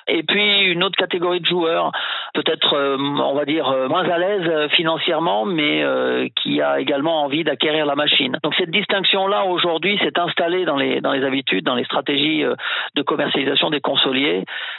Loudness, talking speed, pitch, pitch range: -18 LUFS, 160 wpm, 165 Hz, 145-185 Hz